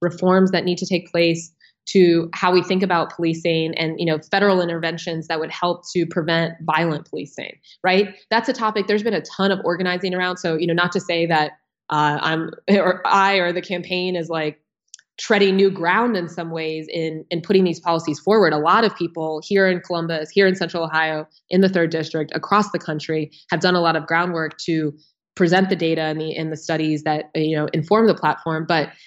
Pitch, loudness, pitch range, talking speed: 170 Hz, -20 LUFS, 160-185 Hz, 215 wpm